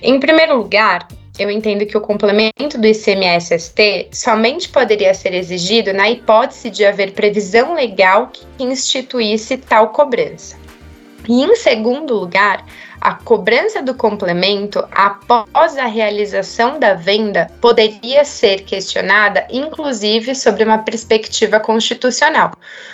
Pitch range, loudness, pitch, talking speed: 200-250 Hz, -13 LUFS, 220 Hz, 120 wpm